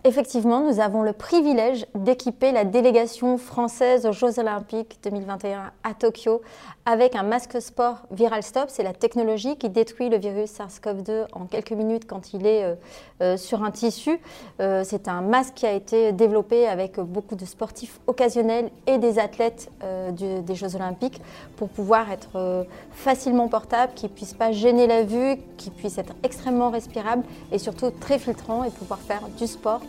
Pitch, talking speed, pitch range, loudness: 225 Hz, 165 wpm, 205-245 Hz, -24 LUFS